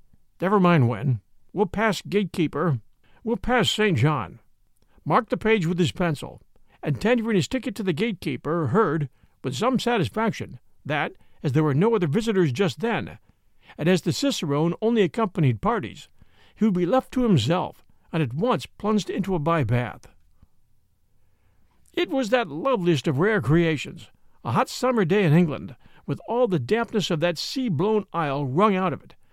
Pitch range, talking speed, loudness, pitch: 150-220 Hz, 165 wpm, -24 LUFS, 180 Hz